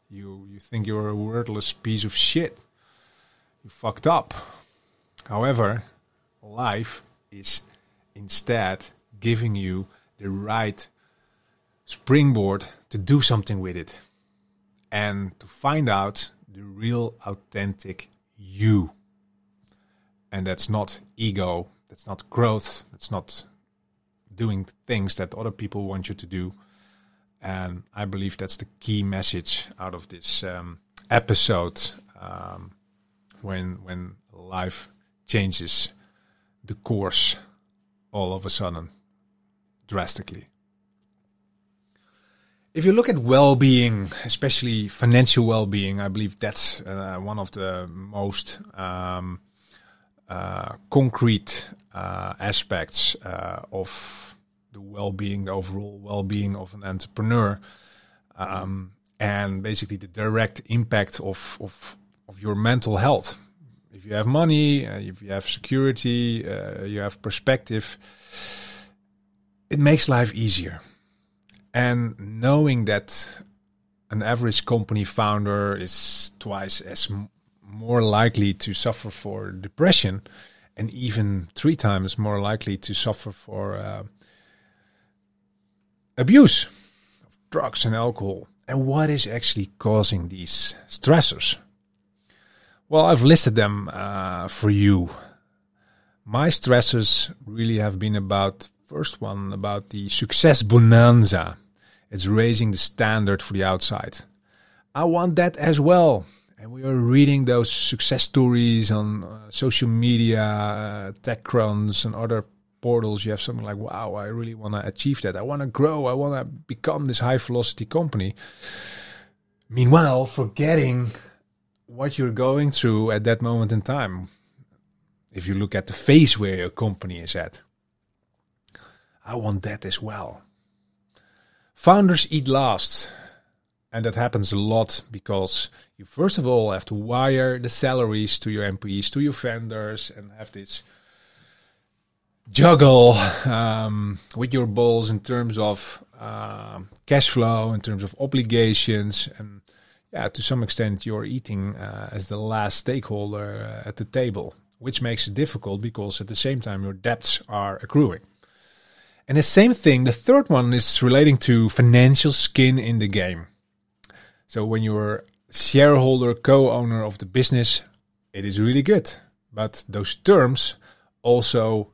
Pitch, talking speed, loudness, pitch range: 105 Hz, 130 wpm, -21 LUFS, 100-120 Hz